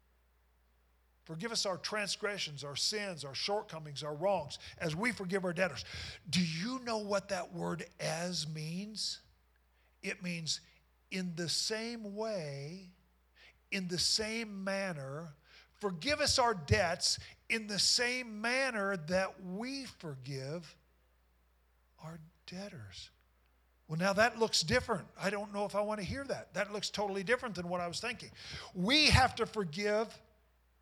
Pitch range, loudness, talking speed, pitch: 145-210 Hz, -35 LUFS, 140 wpm, 185 Hz